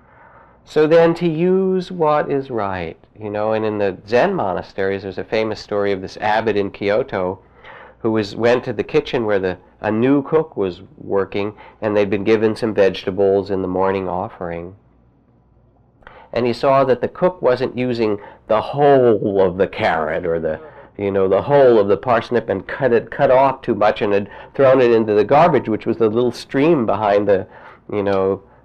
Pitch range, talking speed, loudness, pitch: 100-130 Hz, 190 wpm, -18 LUFS, 110 Hz